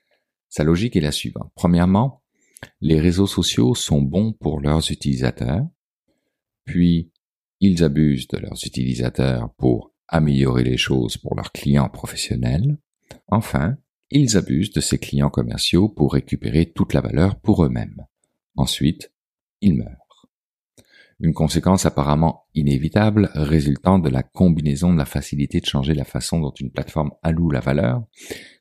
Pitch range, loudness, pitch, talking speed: 70-90 Hz, -20 LUFS, 80 Hz, 140 wpm